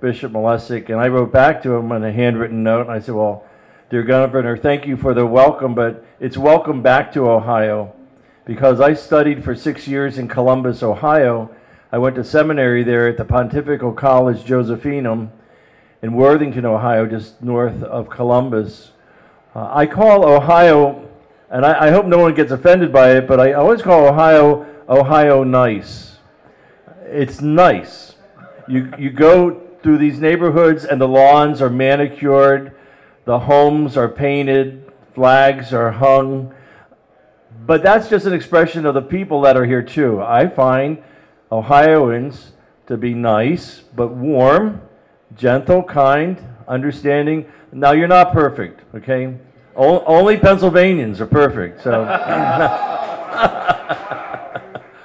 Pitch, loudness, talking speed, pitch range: 135 Hz, -14 LUFS, 140 wpm, 120-150 Hz